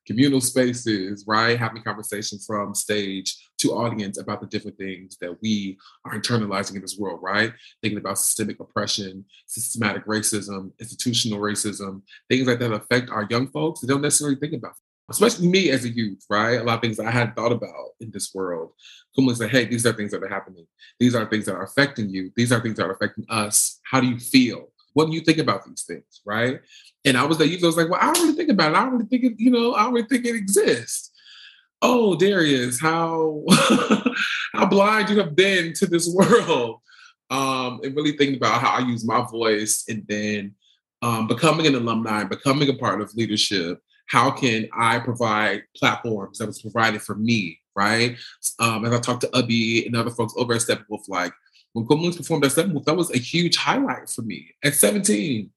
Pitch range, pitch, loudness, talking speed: 105-150 Hz, 120 Hz, -21 LUFS, 210 wpm